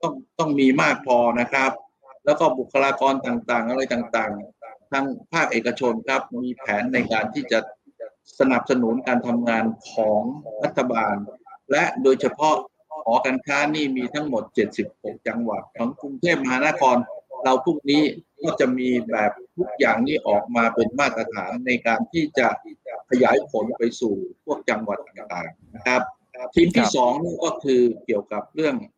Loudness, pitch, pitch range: -22 LUFS, 130 Hz, 120-150 Hz